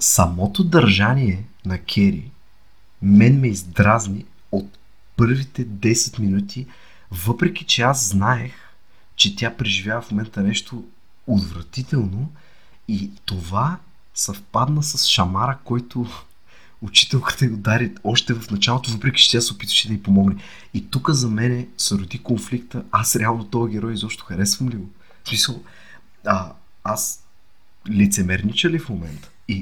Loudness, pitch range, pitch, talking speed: -19 LUFS, 100-125 Hz, 110 Hz, 125 wpm